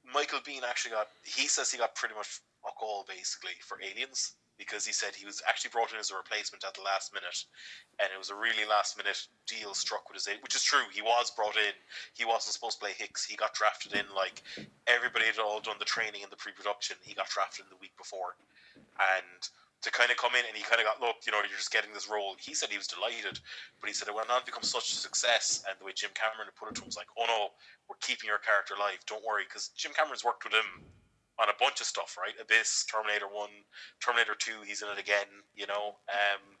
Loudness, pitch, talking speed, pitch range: -32 LUFS, 105 Hz, 255 wpm, 100-110 Hz